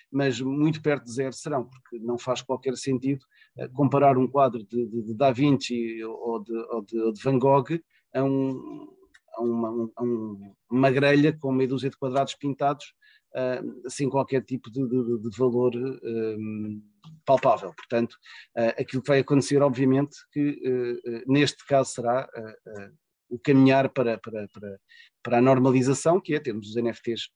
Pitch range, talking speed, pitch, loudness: 115-140 Hz, 175 wpm, 130 Hz, -25 LUFS